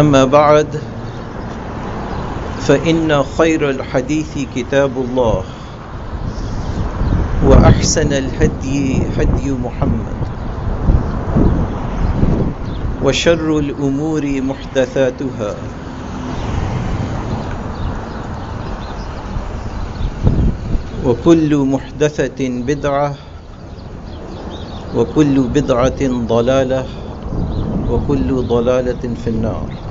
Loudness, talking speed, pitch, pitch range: -17 LUFS, 50 wpm, 125 Hz, 105-140 Hz